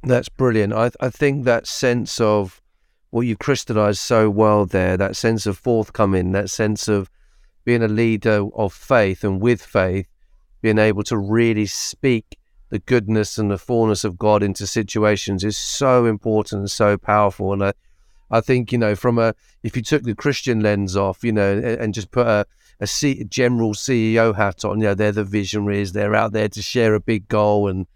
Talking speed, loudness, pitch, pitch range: 200 wpm, -19 LUFS, 105 Hz, 100-115 Hz